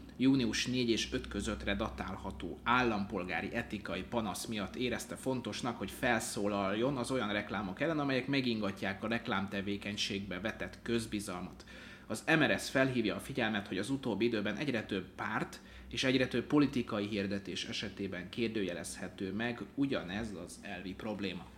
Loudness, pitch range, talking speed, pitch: -35 LUFS, 100-125 Hz, 135 wpm, 110 Hz